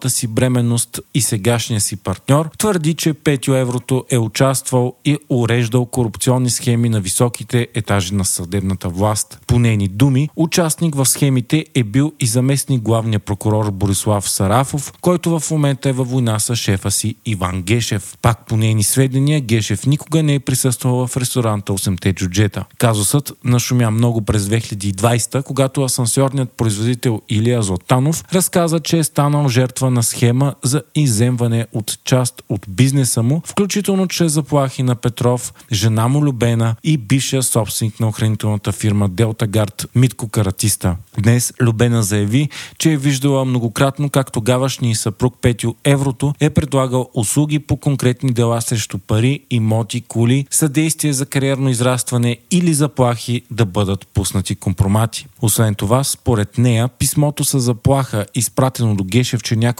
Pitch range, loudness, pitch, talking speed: 110-135 Hz, -16 LUFS, 125 Hz, 145 wpm